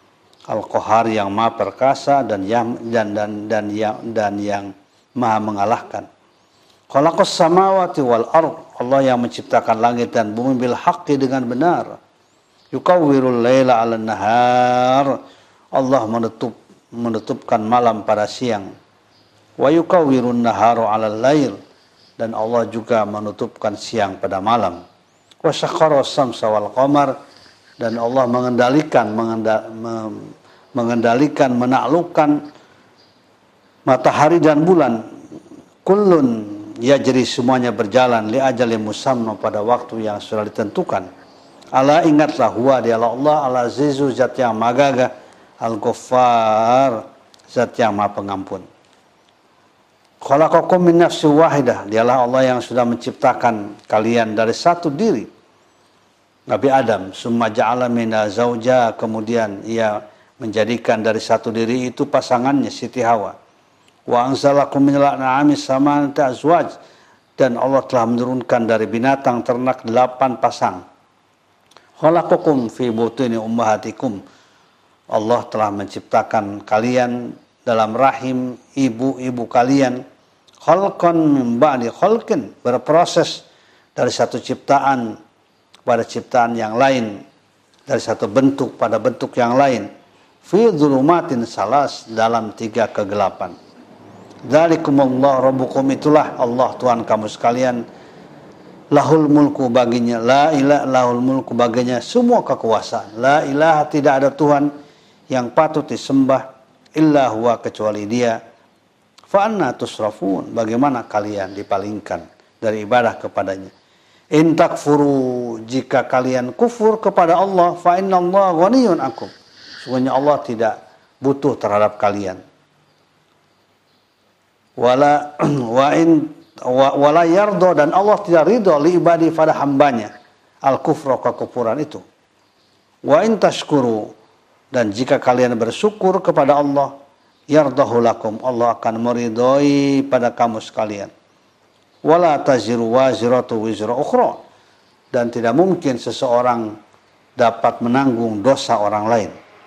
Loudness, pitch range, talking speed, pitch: -16 LUFS, 115-140 Hz, 105 wpm, 125 Hz